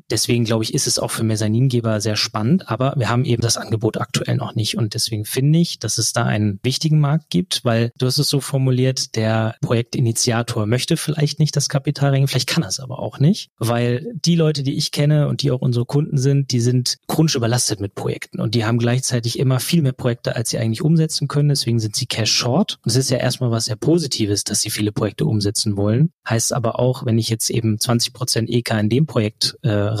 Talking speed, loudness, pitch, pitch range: 230 wpm, -19 LUFS, 125 Hz, 115-140 Hz